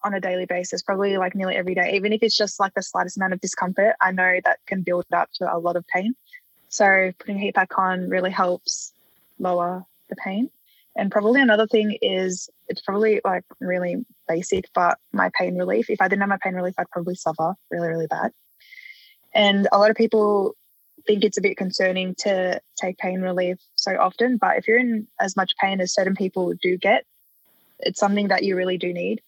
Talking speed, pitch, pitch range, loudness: 210 wpm, 195 Hz, 185-215 Hz, -22 LUFS